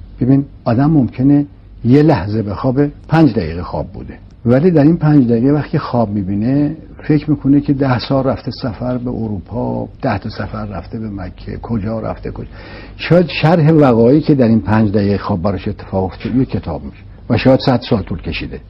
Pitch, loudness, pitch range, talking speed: 115 Hz, -14 LUFS, 100-140 Hz, 185 wpm